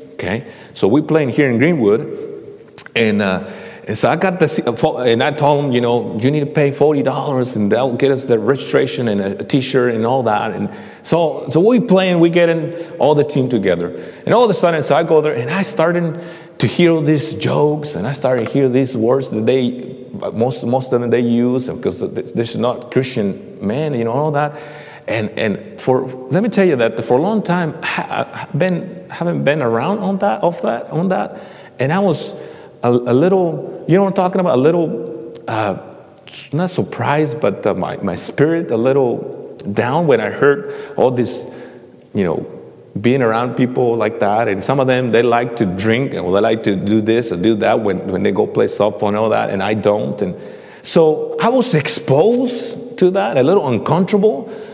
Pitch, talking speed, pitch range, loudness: 145 Hz, 215 wpm, 120-180 Hz, -16 LUFS